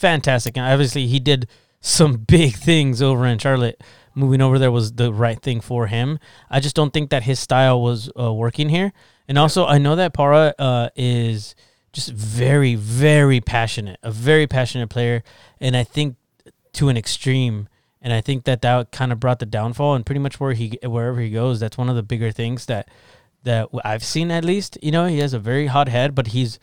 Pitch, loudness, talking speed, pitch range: 125 Hz, -19 LUFS, 210 wpm, 120-145 Hz